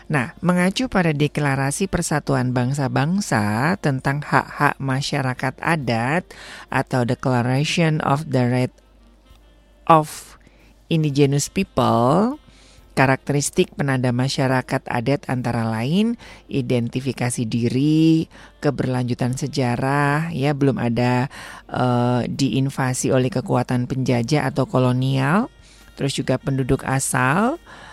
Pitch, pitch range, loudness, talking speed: 135 Hz, 125-150 Hz, -20 LUFS, 90 wpm